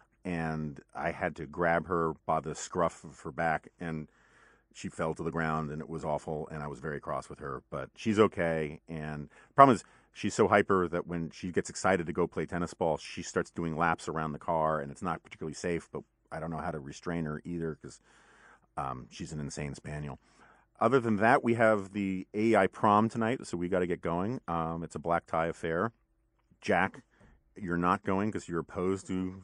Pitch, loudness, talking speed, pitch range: 85 Hz, -32 LUFS, 215 wpm, 80-95 Hz